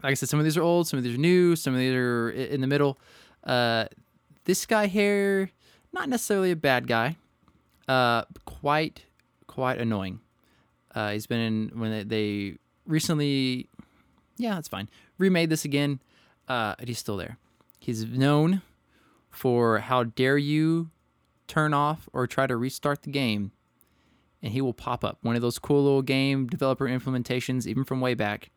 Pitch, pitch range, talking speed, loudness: 130 Hz, 115-150 Hz, 175 wpm, -26 LUFS